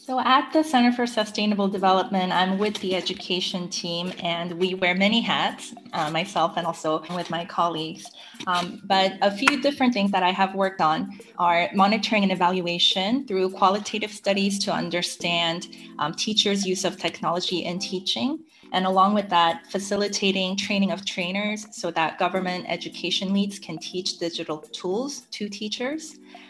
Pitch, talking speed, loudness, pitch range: 190 Hz, 160 wpm, -24 LUFS, 175-210 Hz